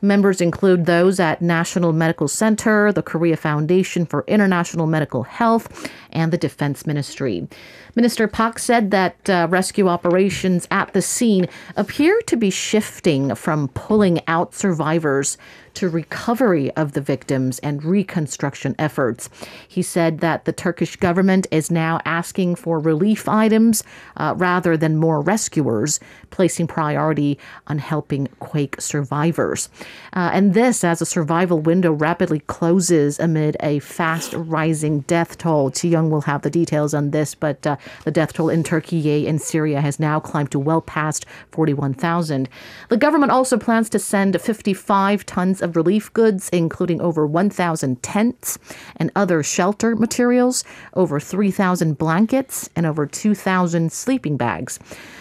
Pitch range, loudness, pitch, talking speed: 155-195 Hz, -19 LUFS, 170 Hz, 145 wpm